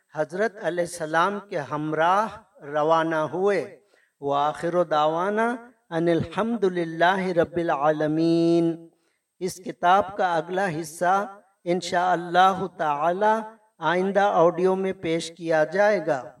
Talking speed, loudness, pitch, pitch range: 100 wpm, -24 LUFS, 175 Hz, 160-195 Hz